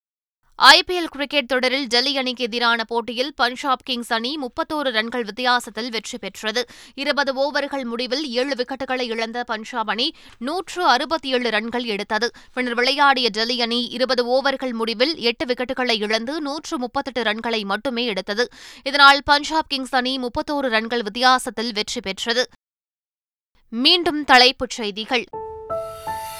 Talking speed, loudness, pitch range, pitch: 125 wpm, -20 LUFS, 235-275 Hz, 250 Hz